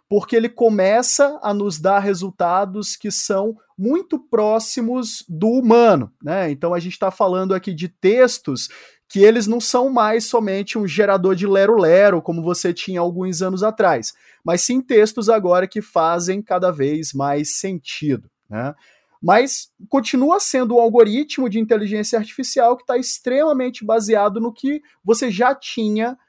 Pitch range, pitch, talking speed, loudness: 185-240 Hz, 215 Hz, 150 wpm, -18 LUFS